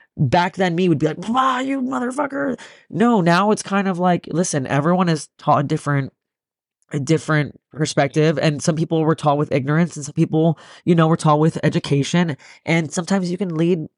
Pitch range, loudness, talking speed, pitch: 150-185 Hz, -19 LUFS, 195 wpm, 165 Hz